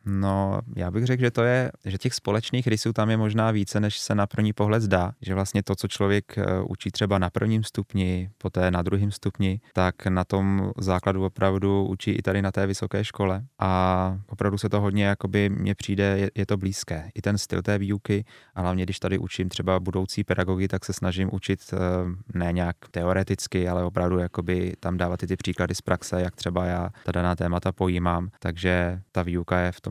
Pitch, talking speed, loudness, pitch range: 95 Hz, 205 wpm, -26 LUFS, 90-105 Hz